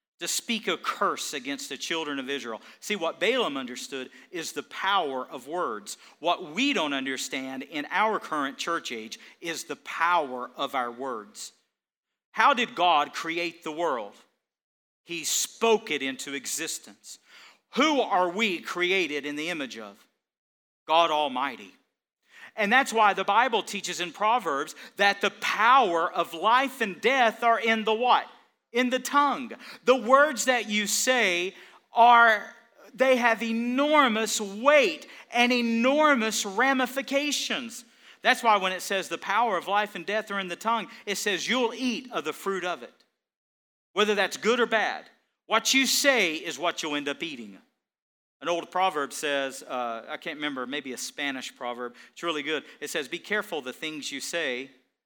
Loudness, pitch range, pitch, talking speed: -26 LUFS, 150-235 Hz, 195 Hz, 165 wpm